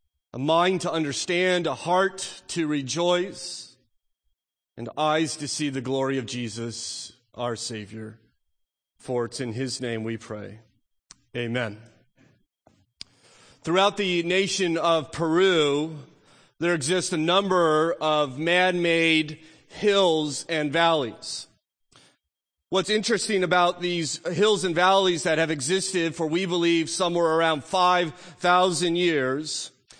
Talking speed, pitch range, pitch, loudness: 120 wpm, 130-180 Hz, 160 Hz, -24 LUFS